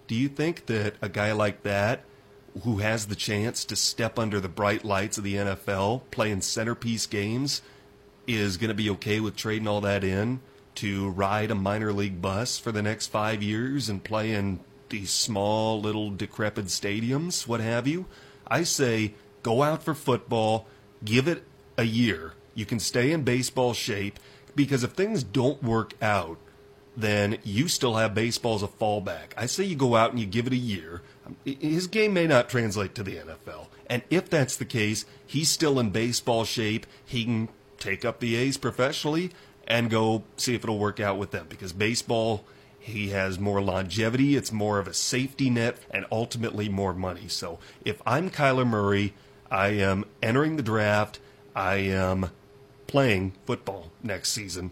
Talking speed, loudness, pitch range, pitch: 180 wpm, -27 LUFS, 100-130 Hz, 110 Hz